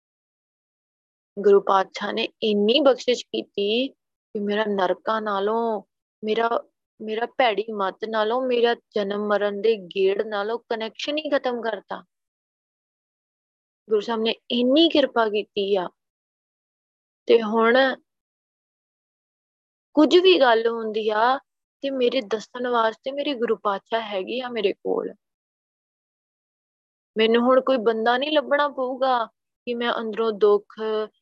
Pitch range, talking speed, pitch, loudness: 210-250 Hz, 115 wpm, 225 Hz, -22 LUFS